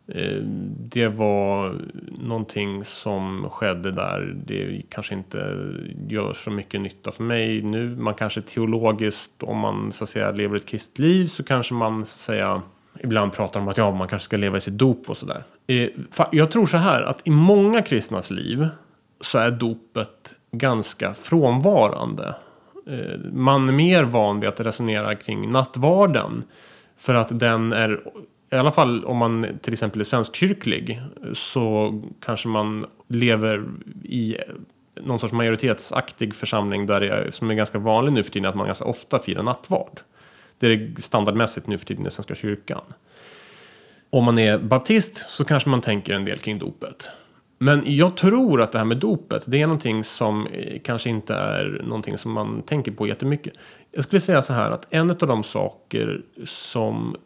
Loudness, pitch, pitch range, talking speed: -22 LUFS, 115 Hz, 105-135 Hz, 170 wpm